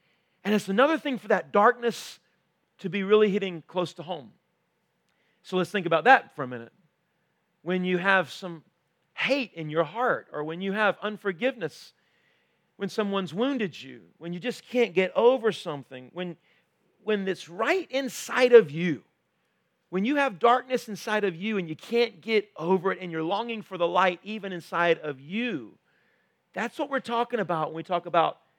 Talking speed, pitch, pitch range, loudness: 180 wpm, 195 Hz, 170-230 Hz, -26 LUFS